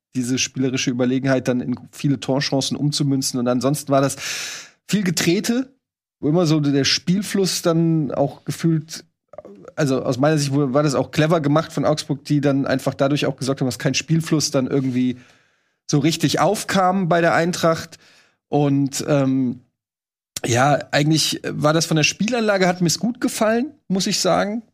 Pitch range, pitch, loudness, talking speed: 135-170 Hz, 145 Hz, -20 LUFS, 160 wpm